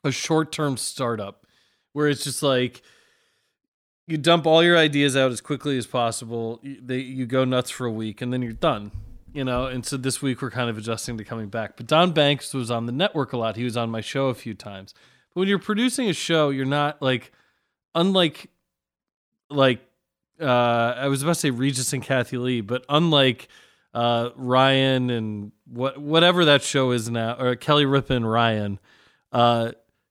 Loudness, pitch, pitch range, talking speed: -22 LUFS, 130 Hz, 120-145 Hz, 195 wpm